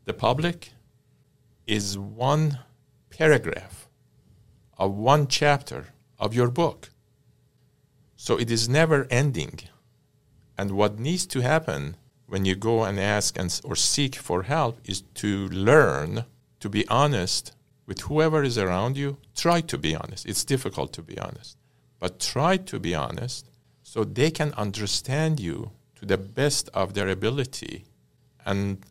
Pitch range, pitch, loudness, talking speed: 105-140 Hz, 125 Hz, -25 LUFS, 140 wpm